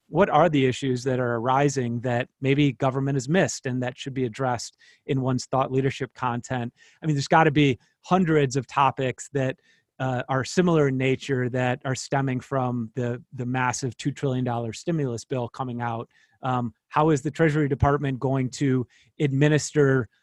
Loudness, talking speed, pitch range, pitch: -25 LUFS, 180 wpm, 125-140 Hz, 130 Hz